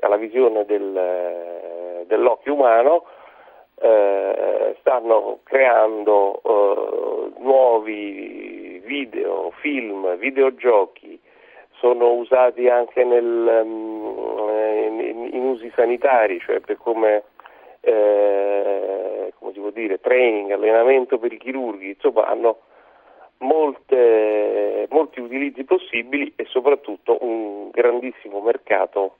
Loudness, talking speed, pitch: -19 LUFS, 95 wpm, 120 Hz